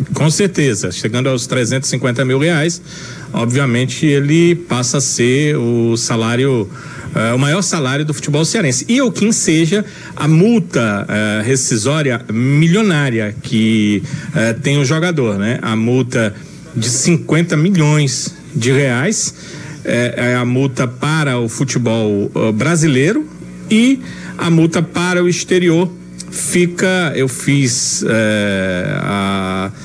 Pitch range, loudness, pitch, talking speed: 120-170 Hz, -14 LUFS, 140 Hz, 130 wpm